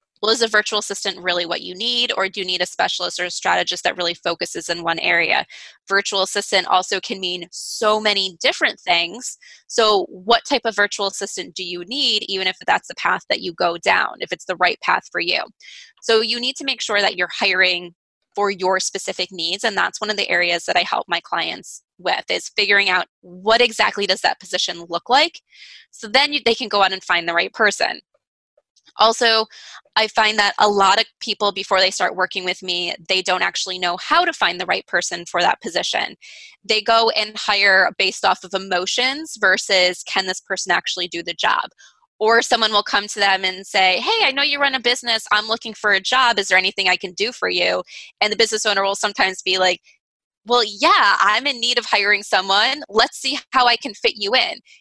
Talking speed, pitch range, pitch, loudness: 220 wpm, 185-225 Hz, 200 Hz, -18 LUFS